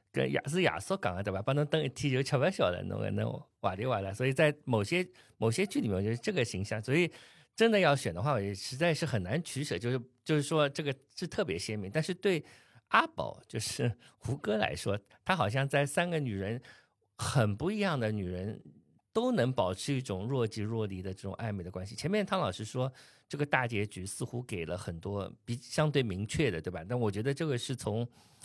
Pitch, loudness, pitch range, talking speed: 125 Hz, -33 LUFS, 105-150 Hz, 315 characters per minute